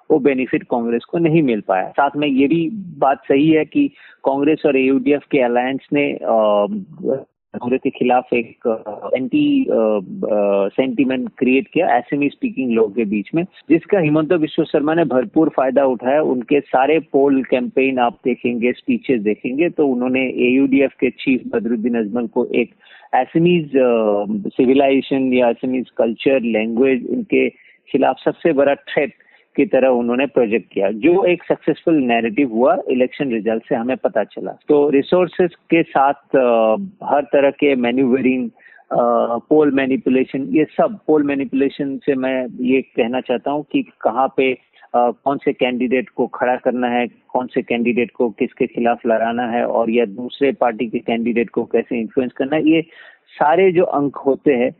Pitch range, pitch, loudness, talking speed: 120-150 Hz, 135 Hz, -17 LUFS, 160 wpm